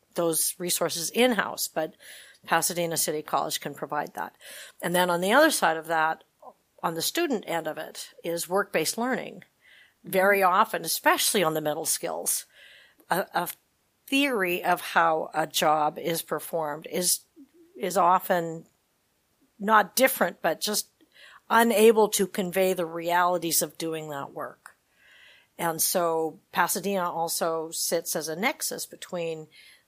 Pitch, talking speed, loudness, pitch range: 175 Hz, 140 wpm, -26 LUFS, 165-205 Hz